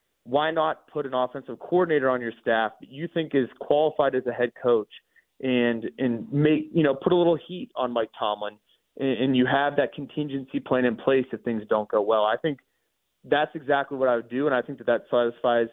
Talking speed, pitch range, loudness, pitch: 220 wpm, 120-150 Hz, -25 LUFS, 135 Hz